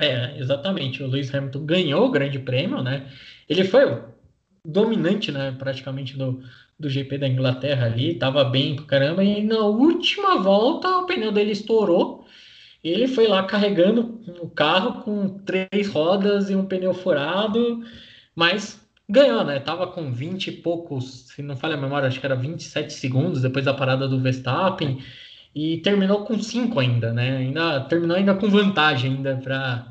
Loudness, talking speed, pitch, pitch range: -22 LUFS, 170 wpm, 160 Hz, 135-200 Hz